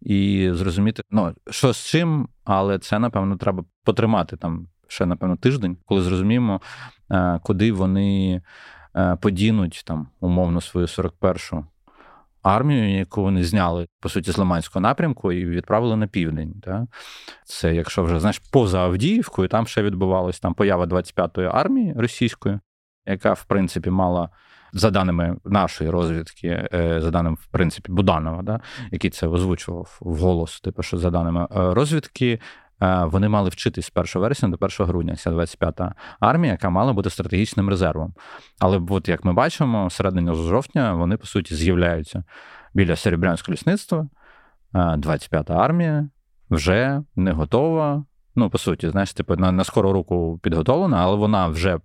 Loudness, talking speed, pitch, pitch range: -21 LUFS, 140 wpm, 95 Hz, 85-105 Hz